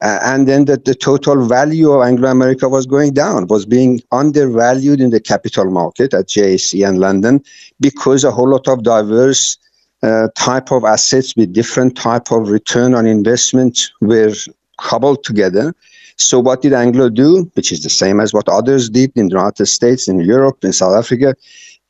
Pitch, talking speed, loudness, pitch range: 125 Hz, 180 wpm, -12 LUFS, 110-135 Hz